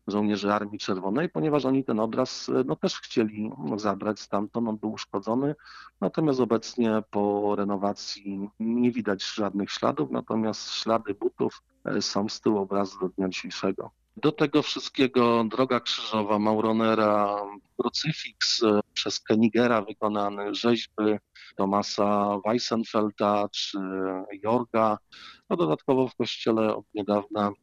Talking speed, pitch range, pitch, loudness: 120 wpm, 100-115 Hz, 110 Hz, -27 LUFS